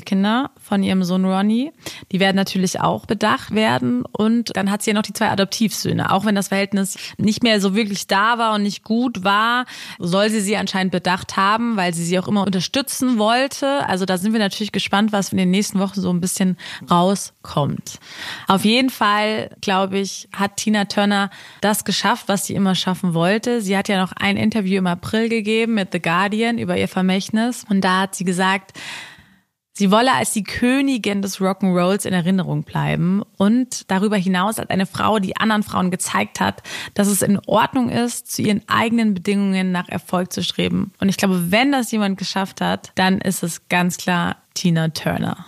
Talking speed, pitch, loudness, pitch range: 195 wpm, 200 Hz, -19 LUFS, 185-215 Hz